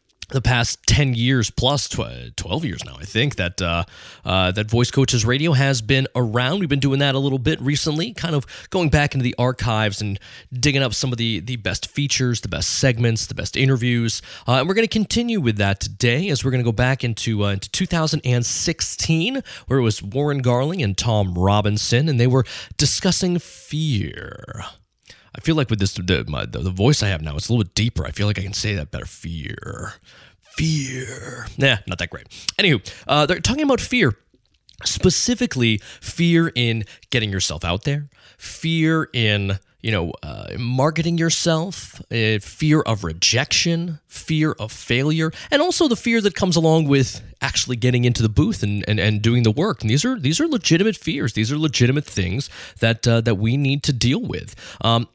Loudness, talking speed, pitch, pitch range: -20 LUFS, 195 wpm, 125 Hz, 105-150 Hz